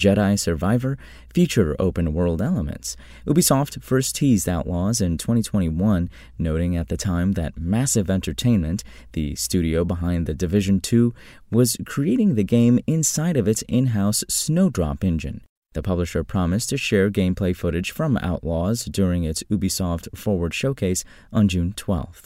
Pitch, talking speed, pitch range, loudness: 95 Hz, 145 wpm, 85-115 Hz, -22 LUFS